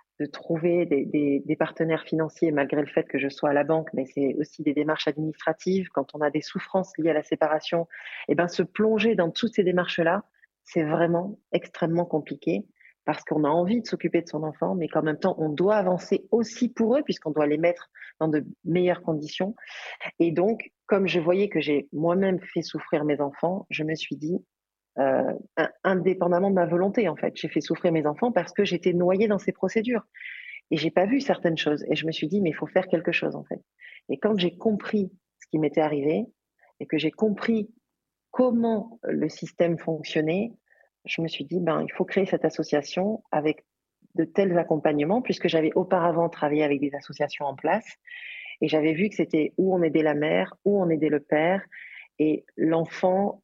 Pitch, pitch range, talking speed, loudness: 170 Hz, 155-195 Hz, 205 wpm, -26 LUFS